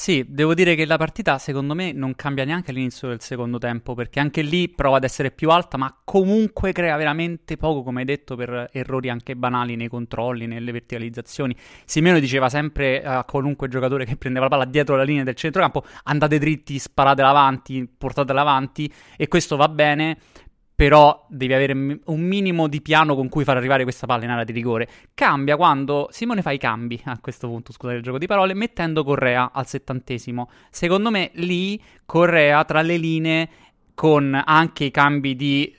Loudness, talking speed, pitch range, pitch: -20 LUFS, 185 wpm, 130-155 Hz, 140 Hz